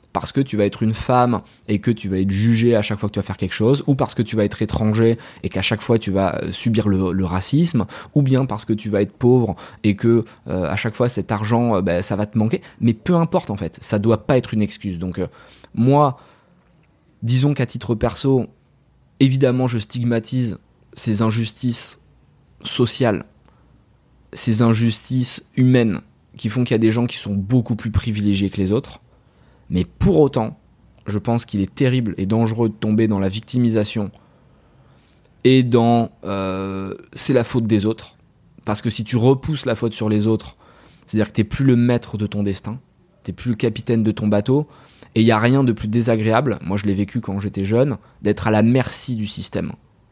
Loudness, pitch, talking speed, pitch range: -19 LUFS, 110 Hz, 205 wpm, 105-120 Hz